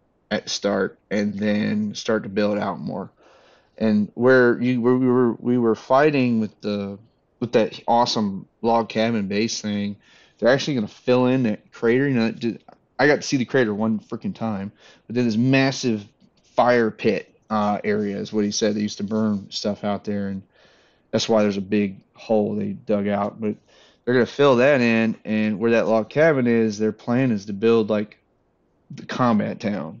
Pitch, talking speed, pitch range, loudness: 110 Hz, 200 wpm, 105-120 Hz, -21 LUFS